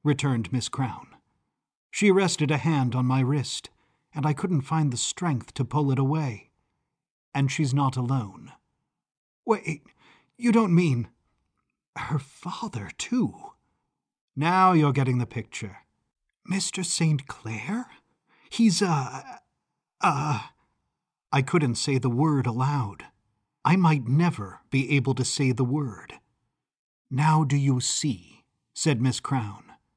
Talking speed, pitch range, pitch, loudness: 130 wpm, 130-160 Hz, 140 Hz, -25 LUFS